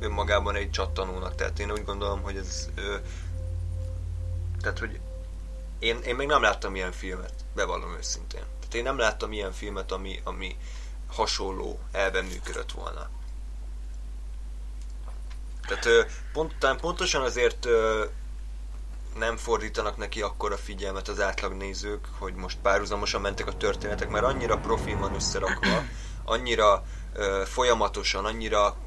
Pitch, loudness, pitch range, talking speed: 85 Hz, -28 LUFS, 60-100 Hz, 130 wpm